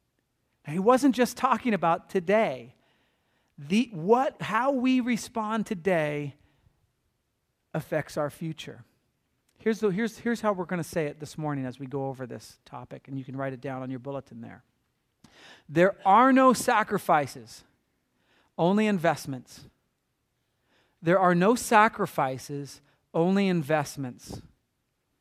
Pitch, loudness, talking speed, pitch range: 165 Hz, -26 LUFS, 130 wpm, 135-215 Hz